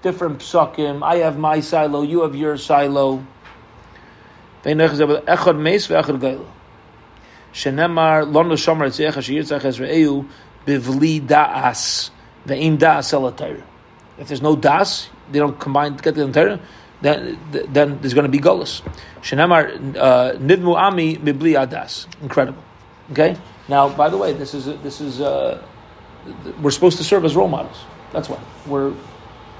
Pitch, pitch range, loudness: 145 Hz, 140-160 Hz, -17 LUFS